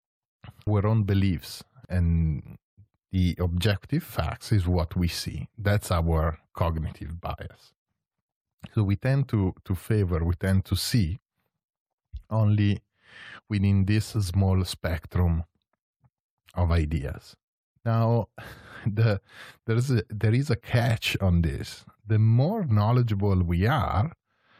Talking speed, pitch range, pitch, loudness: 115 wpm, 90-110 Hz, 100 Hz, -26 LUFS